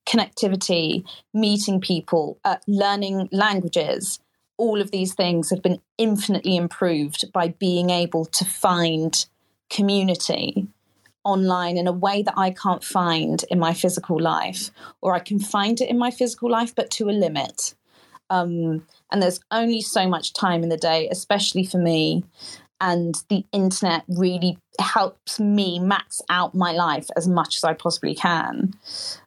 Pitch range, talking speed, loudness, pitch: 170-200 Hz, 150 wpm, -22 LUFS, 185 Hz